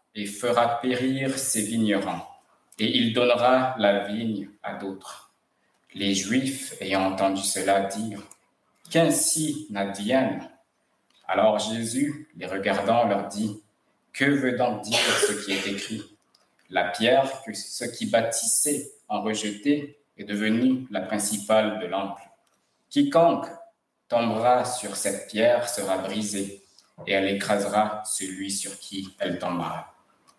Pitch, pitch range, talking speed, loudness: 110 Hz, 100-125 Hz, 125 wpm, -25 LUFS